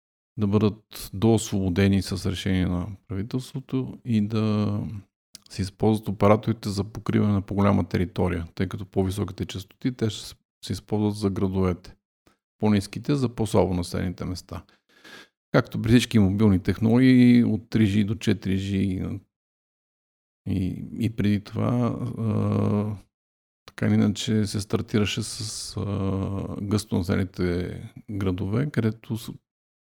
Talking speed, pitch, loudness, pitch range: 115 wpm, 105 Hz, -25 LUFS, 95-110 Hz